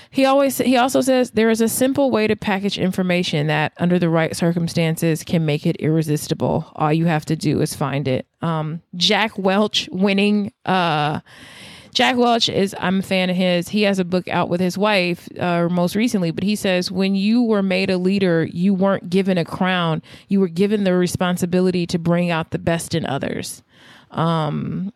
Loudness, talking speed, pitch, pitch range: -19 LUFS, 195 wpm, 180 Hz, 165-200 Hz